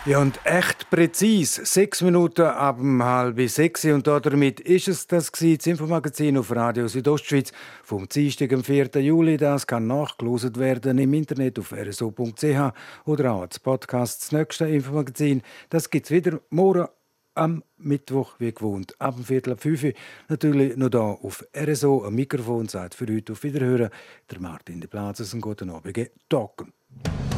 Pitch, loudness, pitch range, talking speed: 140 Hz, -23 LUFS, 120-150 Hz, 165 wpm